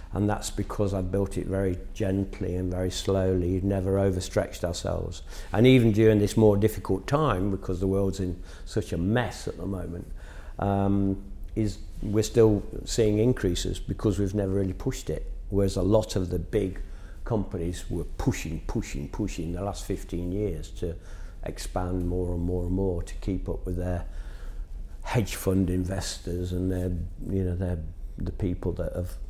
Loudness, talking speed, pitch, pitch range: -28 LUFS, 170 wpm, 95 Hz, 90-100 Hz